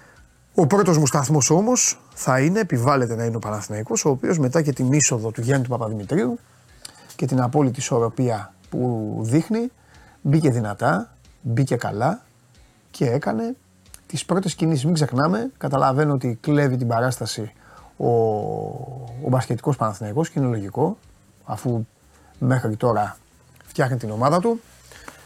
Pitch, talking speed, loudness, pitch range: 130 Hz, 140 wpm, -22 LUFS, 115-155 Hz